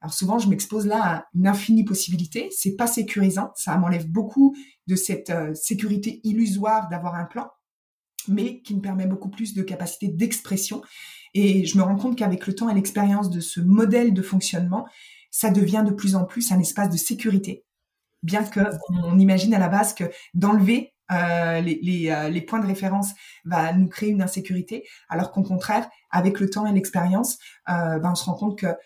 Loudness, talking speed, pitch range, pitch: -22 LUFS, 195 wpm, 180-210 Hz, 195 Hz